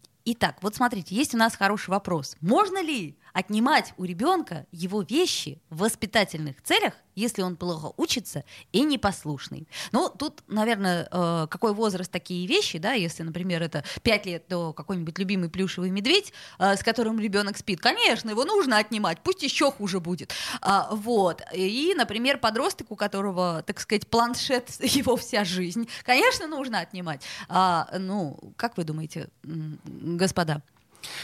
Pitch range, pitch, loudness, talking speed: 175-235 Hz, 200 Hz, -26 LUFS, 140 wpm